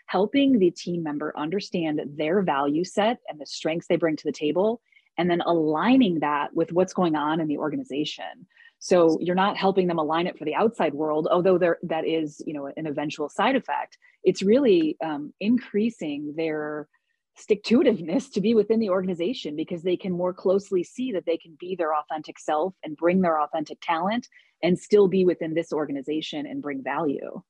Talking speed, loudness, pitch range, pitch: 190 wpm, -25 LUFS, 155-200 Hz, 170 Hz